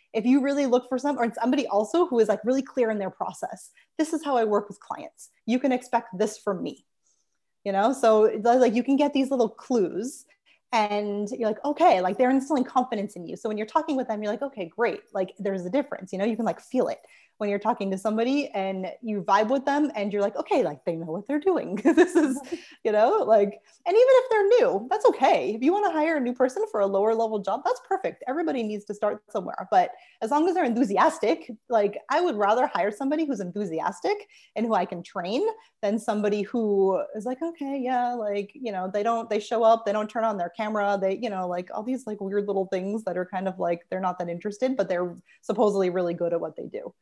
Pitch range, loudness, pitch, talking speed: 200-275 Hz, -25 LUFS, 225 Hz, 245 wpm